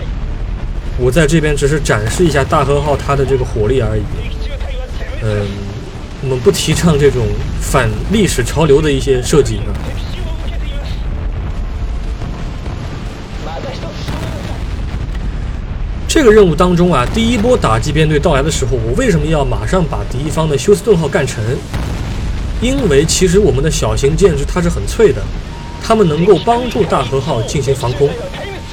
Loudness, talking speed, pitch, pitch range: -14 LUFS, 215 characters per minute, 135 Hz, 105-160 Hz